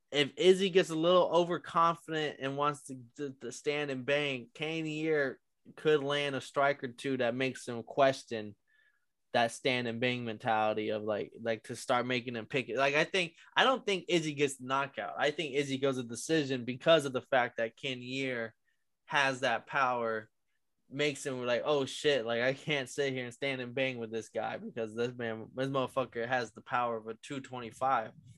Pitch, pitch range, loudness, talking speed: 135 Hz, 120-150 Hz, -32 LUFS, 200 wpm